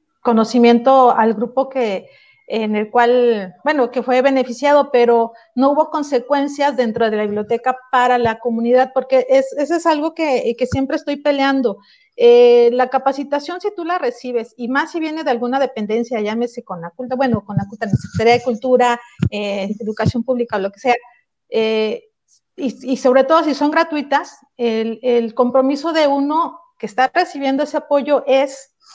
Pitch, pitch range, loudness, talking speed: 255 Hz, 235-290 Hz, -16 LUFS, 170 wpm